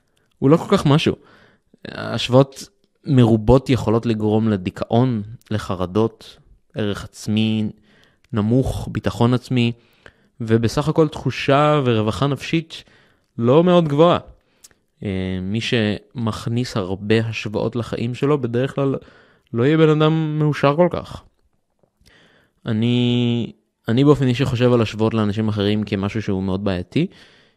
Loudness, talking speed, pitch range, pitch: -19 LUFS, 115 wpm, 110-135 Hz, 115 Hz